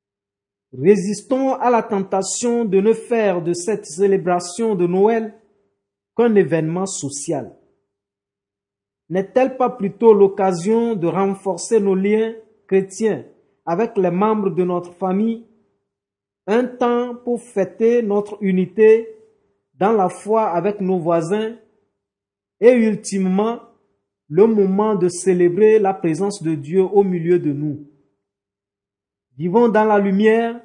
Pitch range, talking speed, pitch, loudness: 165-220 Hz, 115 wpm, 195 Hz, -18 LUFS